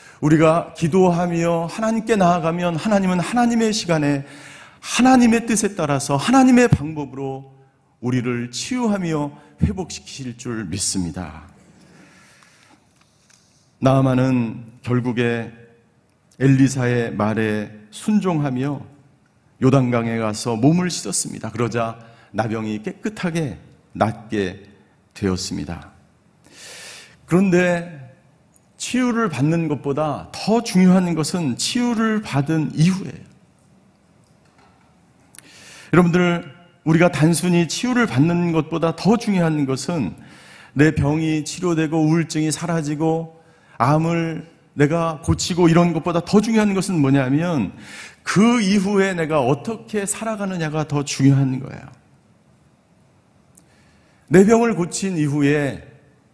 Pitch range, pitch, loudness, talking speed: 130-180 Hz, 155 Hz, -19 LUFS, 235 characters per minute